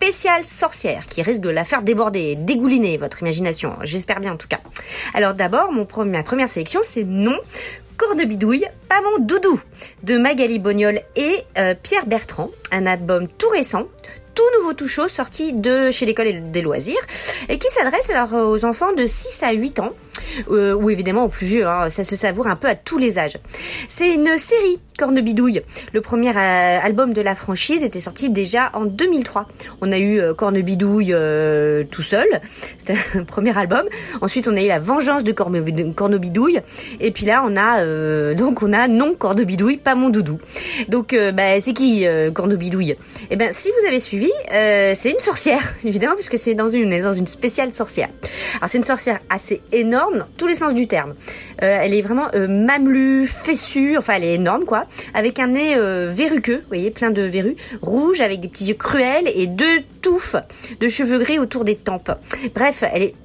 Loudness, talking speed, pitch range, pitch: -18 LUFS, 200 wpm, 195-265 Hz, 225 Hz